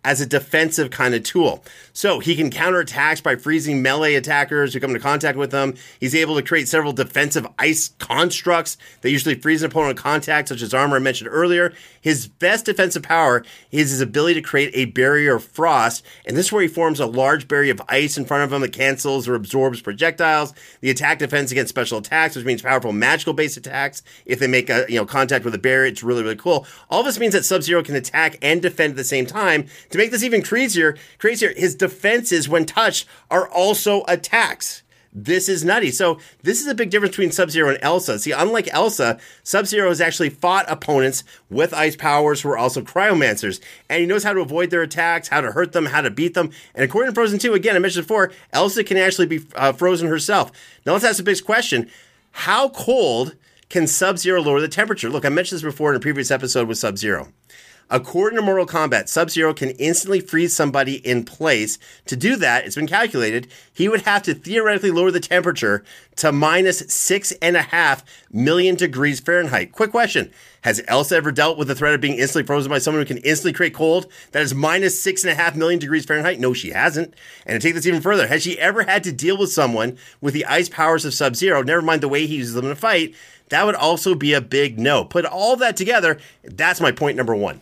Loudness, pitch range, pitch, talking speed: -18 LUFS, 140-180 Hz, 160 Hz, 225 wpm